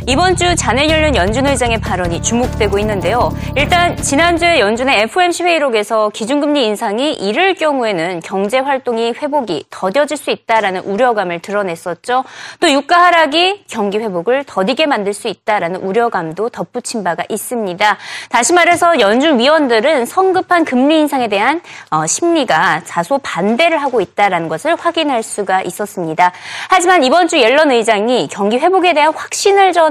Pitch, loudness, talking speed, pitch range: 245 Hz, -13 LUFS, 360 characters per minute, 205-325 Hz